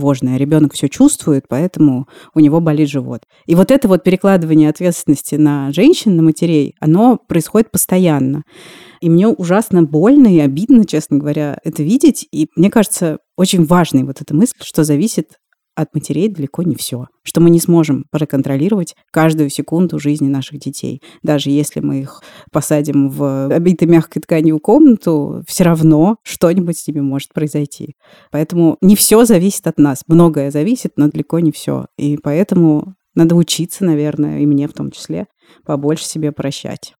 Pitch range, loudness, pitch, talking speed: 145-180 Hz, -13 LUFS, 155 Hz, 160 wpm